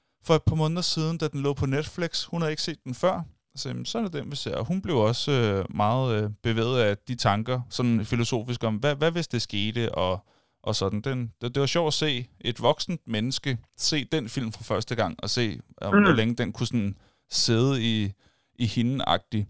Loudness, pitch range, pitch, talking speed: -26 LUFS, 110-145 Hz, 120 Hz, 210 wpm